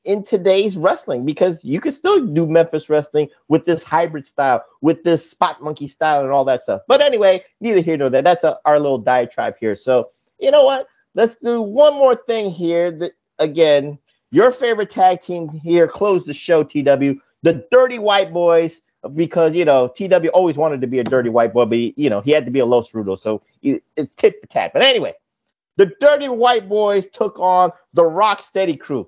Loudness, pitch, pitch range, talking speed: -16 LUFS, 170 Hz, 145-210 Hz, 210 wpm